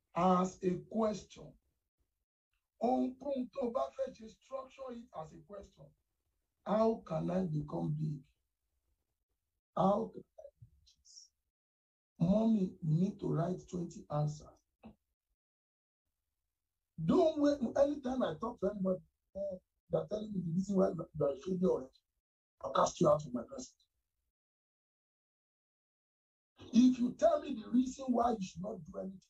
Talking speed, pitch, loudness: 125 wpm, 180 Hz, -35 LUFS